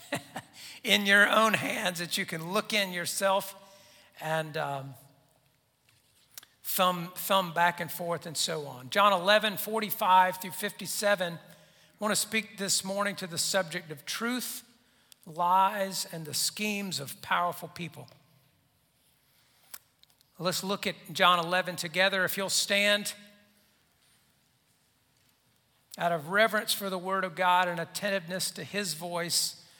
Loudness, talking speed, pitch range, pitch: -28 LUFS, 130 wpm, 165-200 Hz, 185 Hz